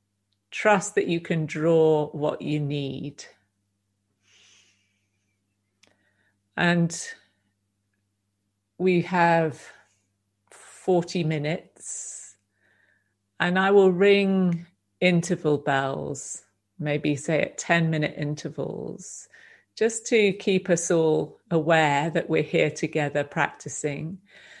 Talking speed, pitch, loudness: 90 wpm, 150 Hz, -24 LUFS